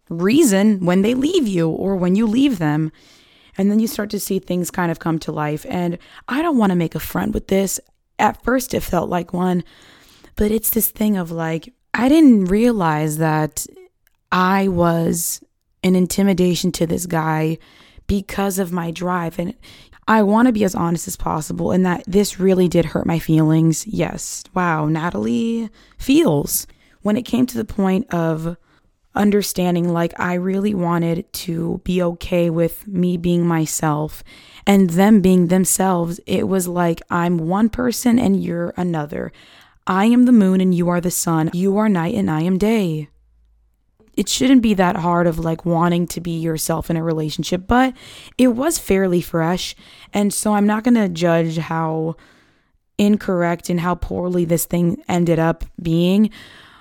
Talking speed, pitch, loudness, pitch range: 175 wpm, 180 Hz, -18 LUFS, 170-205 Hz